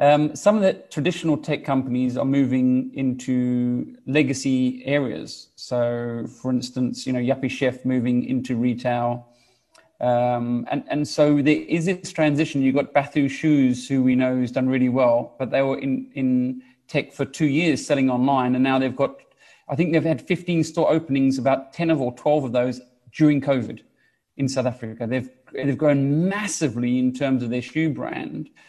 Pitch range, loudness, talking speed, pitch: 125-145 Hz, -22 LUFS, 180 wpm, 130 Hz